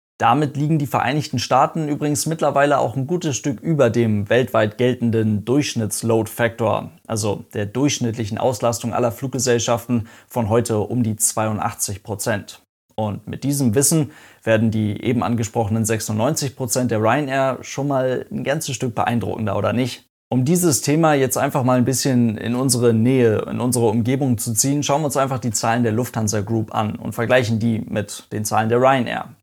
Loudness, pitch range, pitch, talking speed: -20 LUFS, 110-135 Hz, 120 Hz, 165 wpm